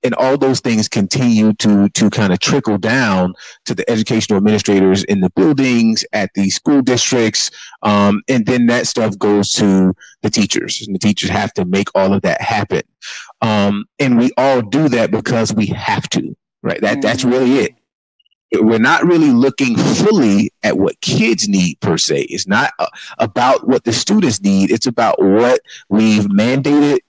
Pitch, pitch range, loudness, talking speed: 110 Hz, 100-125 Hz, -14 LUFS, 175 wpm